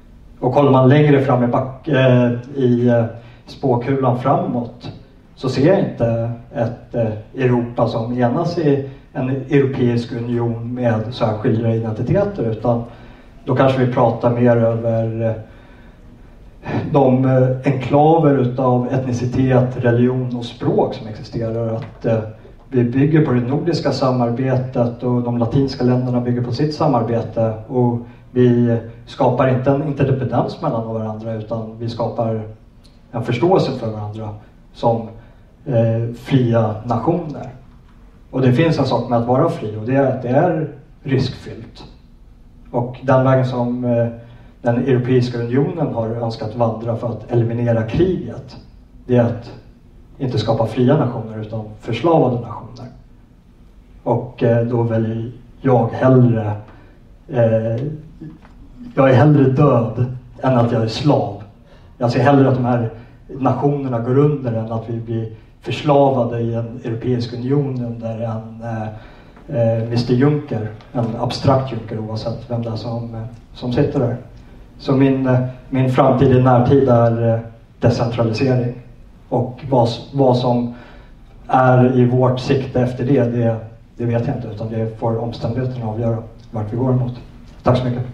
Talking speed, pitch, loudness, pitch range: 140 wpm, 120 Hz, -18 LUFS, 115-130 Hz